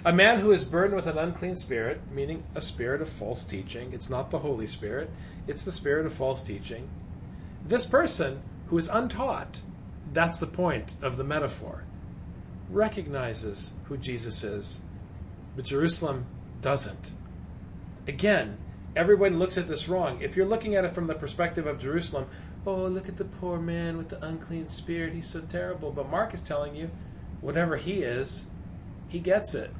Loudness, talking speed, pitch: -29 LUFS, 170 wpm, 150 Hz